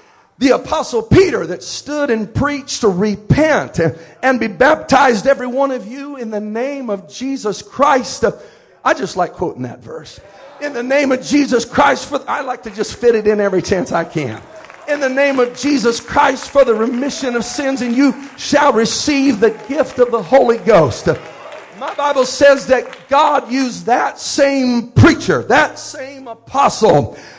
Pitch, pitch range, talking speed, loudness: 265 Hz, 235-280 Hz, 175 wpm, -15 LUFS